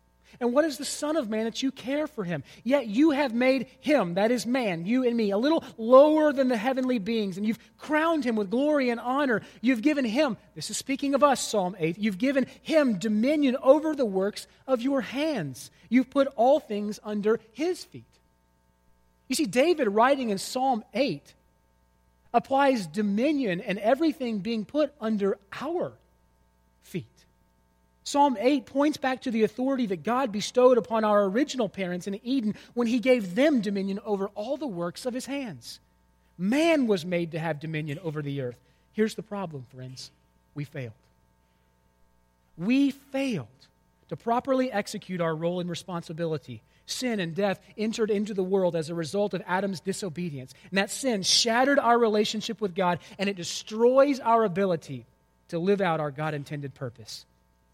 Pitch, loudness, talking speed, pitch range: 210 Hz, -26 LUFS, 175 wpm, 160-260 Hz